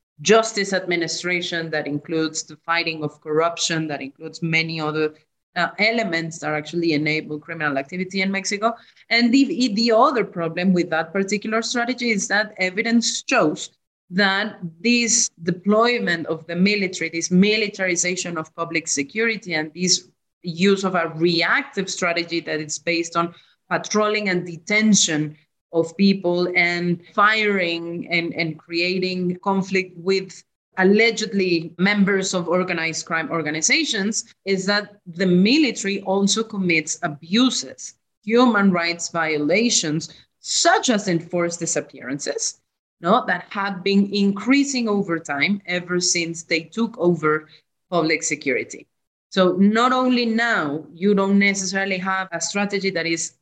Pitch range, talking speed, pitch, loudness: 165-205 Hz, 130 wpm, 180 Hz, -20 LUFS